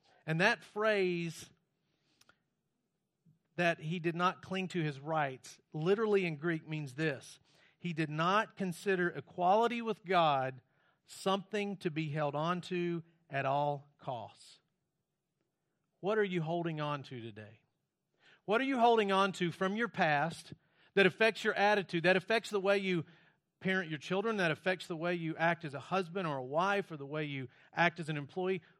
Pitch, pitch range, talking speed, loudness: 170 Hz, 155-190 Hz, 165 wpm, -34 LUFS